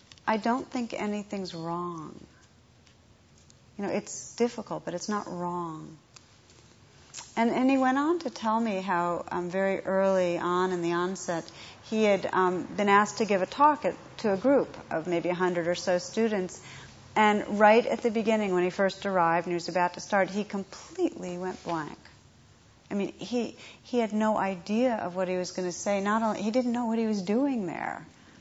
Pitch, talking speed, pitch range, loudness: 195 Hz, 190 wpm, 175-220 Hz, -28 LUFS